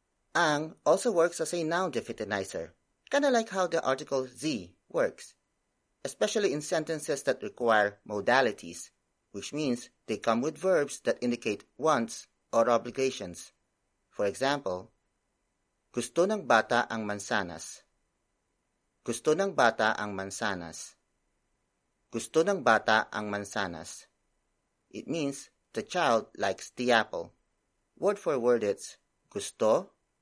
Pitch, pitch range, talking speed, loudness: 130 Hz, 110-170 Hz, 120 wpm, -30 LUFS